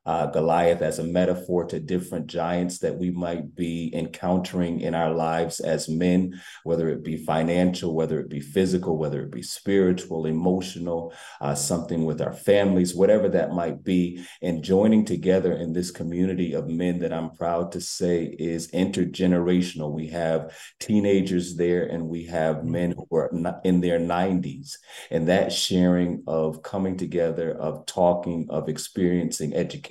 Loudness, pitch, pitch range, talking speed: -25 LUFS, 85 Hz, 80-90 Hz, 160 wpm